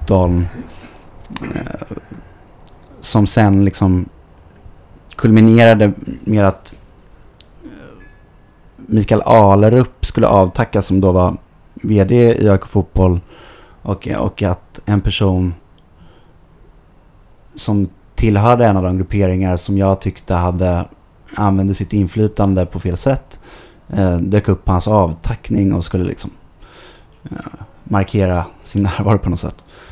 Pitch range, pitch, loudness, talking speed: 90-105 Hz, 100 Hz, -15 LUFS, 100 wpm